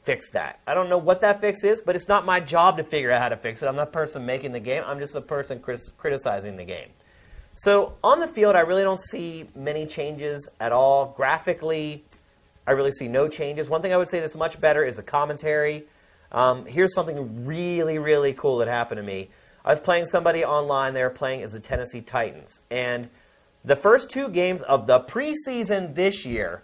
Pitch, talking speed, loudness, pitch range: 150 Hz, 215 wpm, -23 LUFS, 130-180 Hz